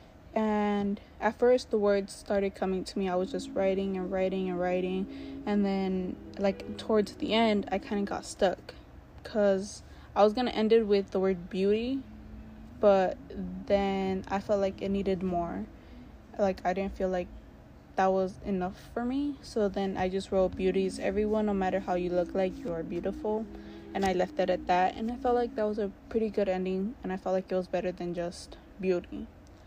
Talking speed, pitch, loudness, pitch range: 200 wpm, 195 Hz, -30 LUFS, 185-210 Hz